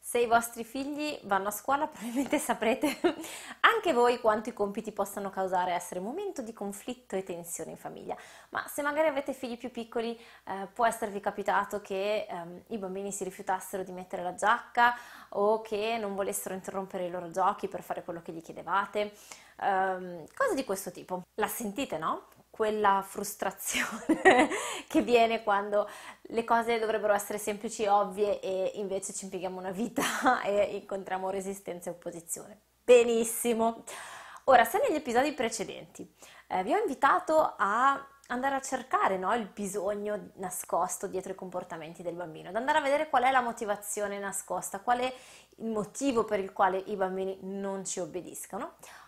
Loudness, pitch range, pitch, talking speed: -30 LUFS, 190-240 Hz, 205 Hz, 165 wpm